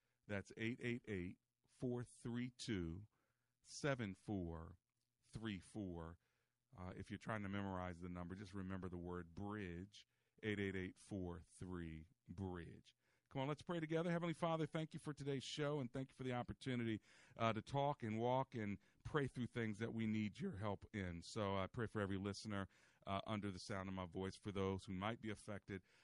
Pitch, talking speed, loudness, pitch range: 105 Hz, 160 wpm, -47 LUFS, 95-120 Hz